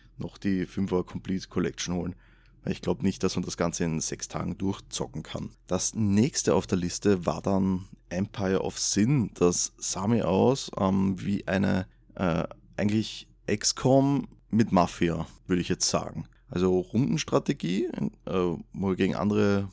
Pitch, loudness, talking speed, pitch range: 95 Hz, -28 LUFS, 155 wpm, 90-100 Hz